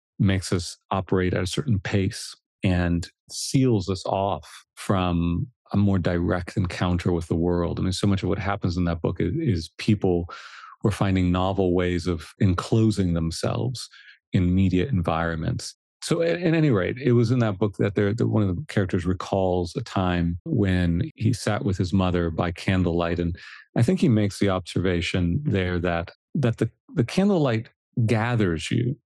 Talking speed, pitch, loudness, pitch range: 175 wpm, 95 Hz, -24 LUFS, 90-110 Hz